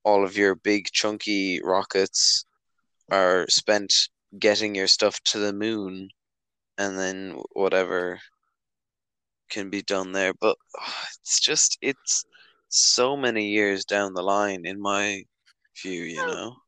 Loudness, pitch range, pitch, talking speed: -23 LUFS, 95-105 Hz, 100 Hz, 135 wpm